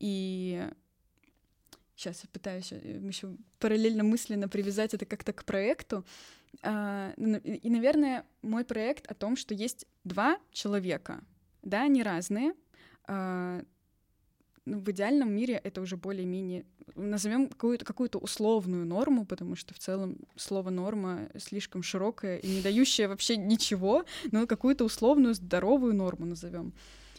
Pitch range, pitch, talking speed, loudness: 190-235 Hz, 210 Hz, 125 wpm, -31 LUFS